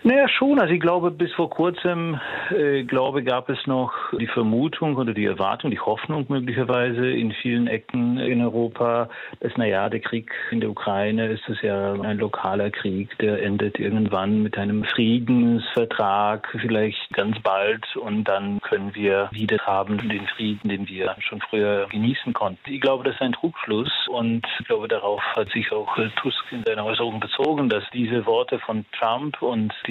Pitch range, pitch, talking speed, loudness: 105-135 Hz, 115 Hz, 175 wpm, -23 LUFS